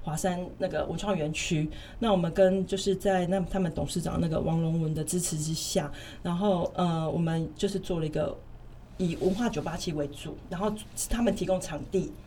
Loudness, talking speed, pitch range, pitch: -29 LUFS, 285 characters per minute, 155-190 Hz, 180 Hz